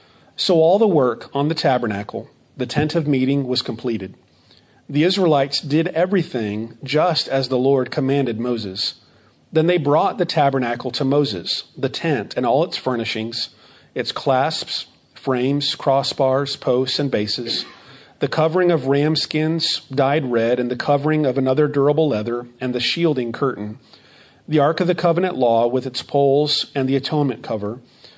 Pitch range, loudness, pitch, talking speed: 125-150 Hz, -19 LUFS, 135 Hz, 160 wpm